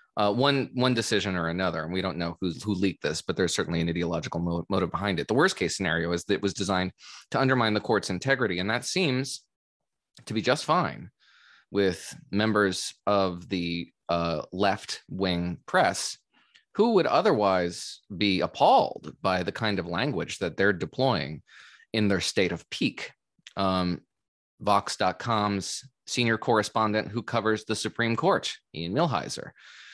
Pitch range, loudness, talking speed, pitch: 90-110 Hz, -27 LUFS, 160 wpm, 100 Hz